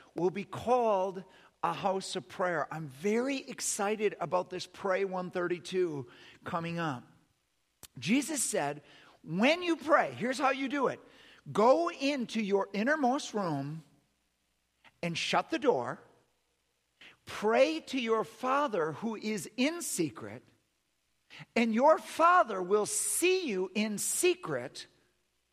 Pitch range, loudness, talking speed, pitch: 165-255 Hz, -31 LUFS, 120 wpm, 195 Hz